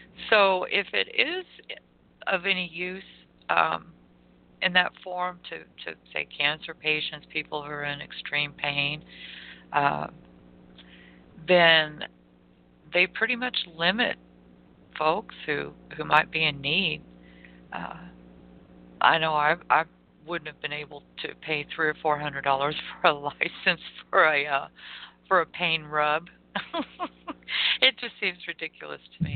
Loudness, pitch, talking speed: -26 LUFS, 150 Hz, 135 wpm